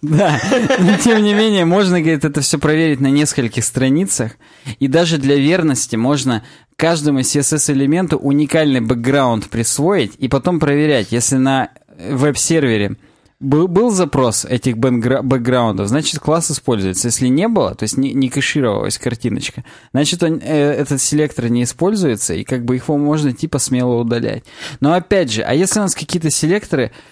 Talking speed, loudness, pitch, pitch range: 155 wpm, -15 LUFS, 140 Hz, 125-160 Hz